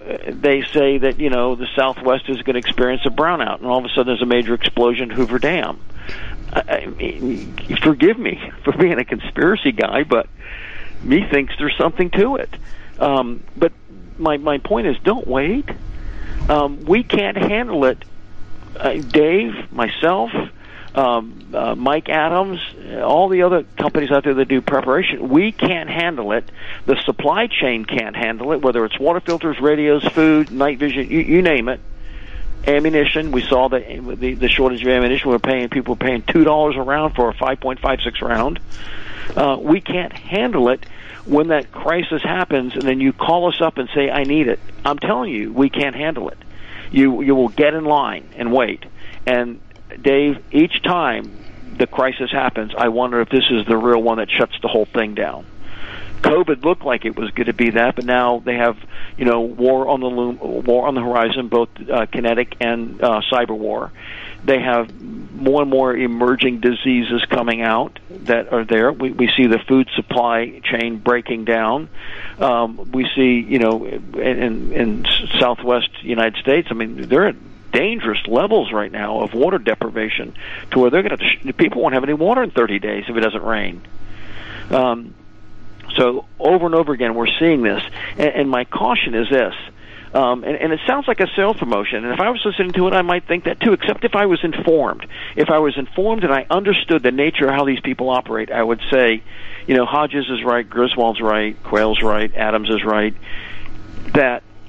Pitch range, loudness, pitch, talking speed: 115-145 Hz, -17 LUFS, 125 Hz, 190 wpm